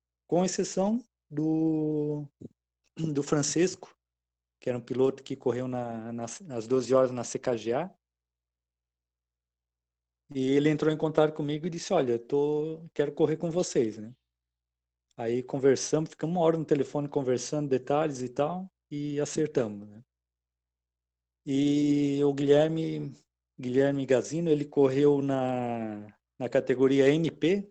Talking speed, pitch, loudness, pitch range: 130 wpm, 135 Hz, -28 LUFS, 105-150 Hz